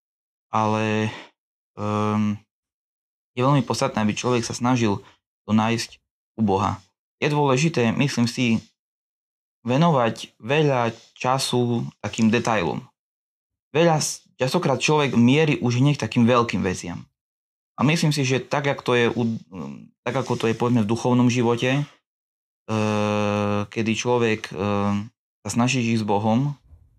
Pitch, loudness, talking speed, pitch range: 115 Hz, -22 LUFS, 120 wpm, 105-130 Hz